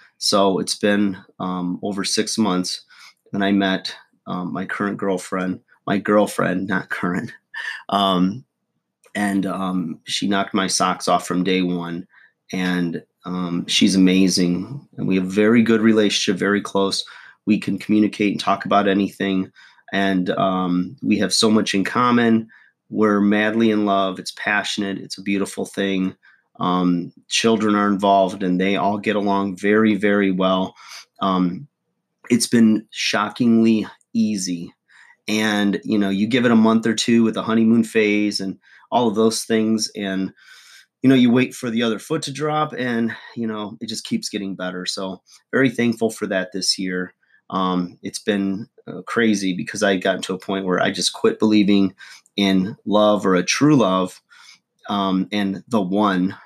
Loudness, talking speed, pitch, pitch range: -20 LUFS, 165 wpm, 100 Hz, 95-110 Hz